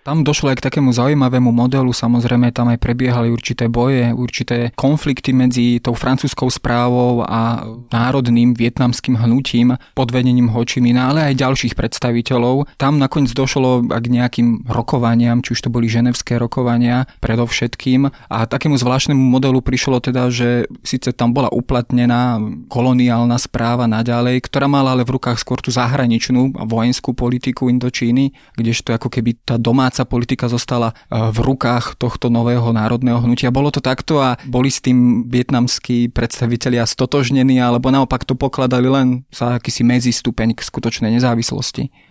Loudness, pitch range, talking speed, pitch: -16 LUFS, 120-130 Hz, 145 wpm, 125 Hz